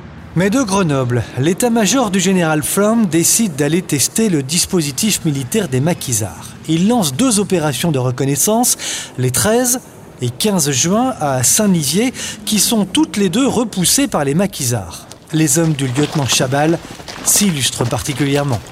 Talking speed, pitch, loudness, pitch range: 140 wpm, 165 Hz, -15 LUFS, 140-215 Hz